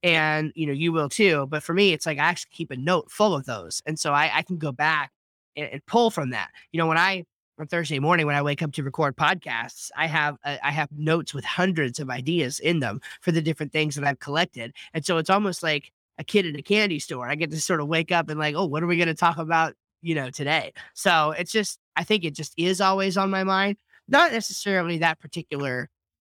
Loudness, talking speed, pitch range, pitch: -24 LUFS, 255 wpm, 150-175 Hz, 160 Hz